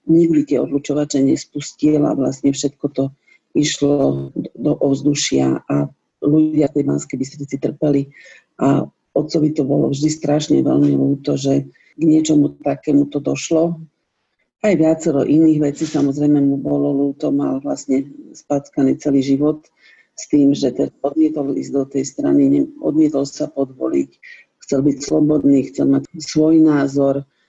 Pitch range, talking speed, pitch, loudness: 140-155 Hz, 135 wpm, 145 Hz, -17 LUFS